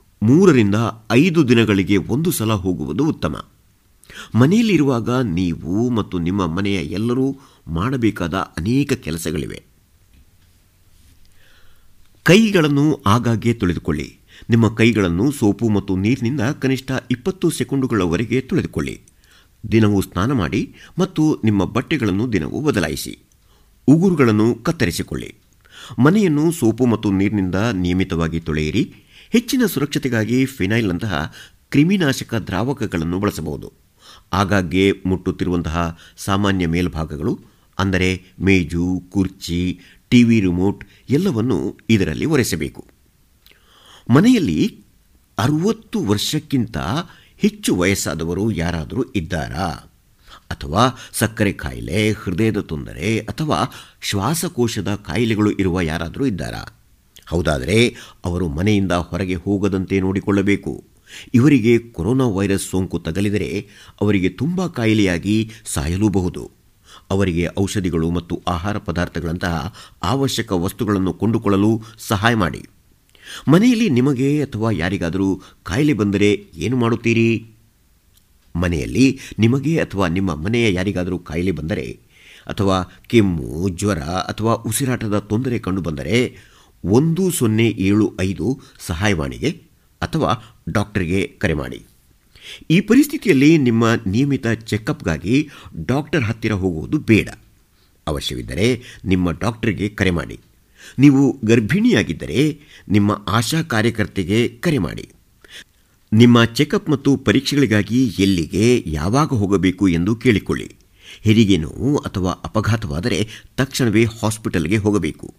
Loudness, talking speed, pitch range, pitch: -18 LUFS, 90 wpm, 90-120 Hz, 105 Hz